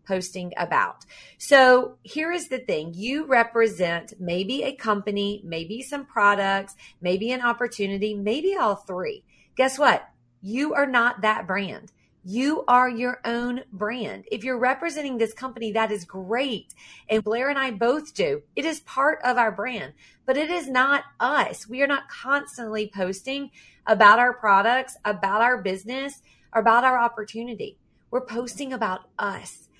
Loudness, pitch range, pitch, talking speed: -23 LUFS, 210-265 Hz, 235 Hz, 155 wpm